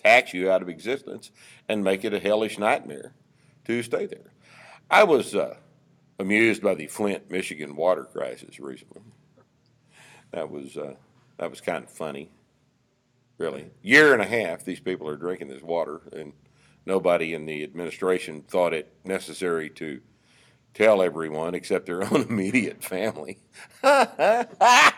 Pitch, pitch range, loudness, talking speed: 95 Hz, 80-110 Hz, -24 LUFS, 145 wpm